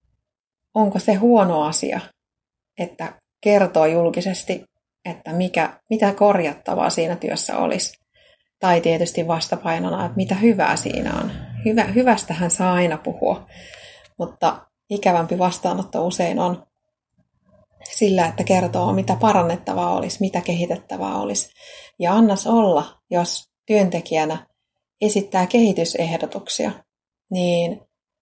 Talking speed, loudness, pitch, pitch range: 105 wpm, -19 LUFS, 180 Hz, 170-205 Hz